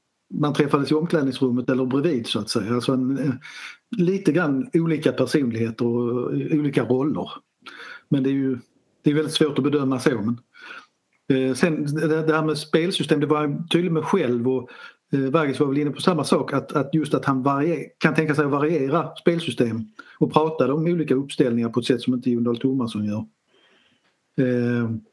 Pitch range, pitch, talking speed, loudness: 130-155 Hz, 145 Hz, 185 wpm, -22 LUFS